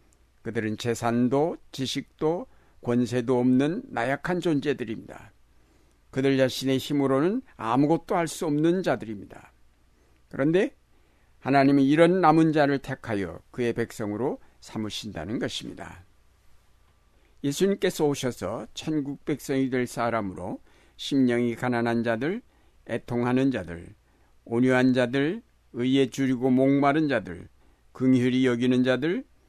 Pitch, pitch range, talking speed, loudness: 125 Hz, 115-140 Hz, 265 characters per minute, -25 LUFS